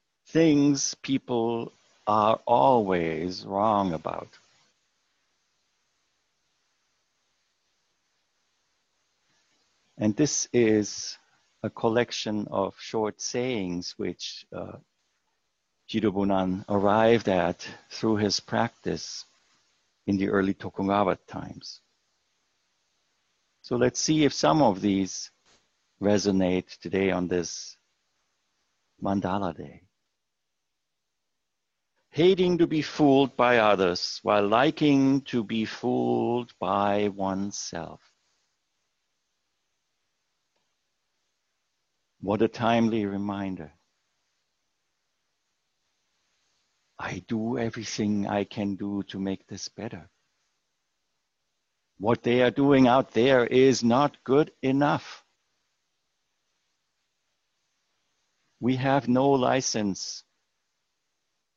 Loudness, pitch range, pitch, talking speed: -25 LUFS, 95-125 Hz, 105 Hz, 80 wpm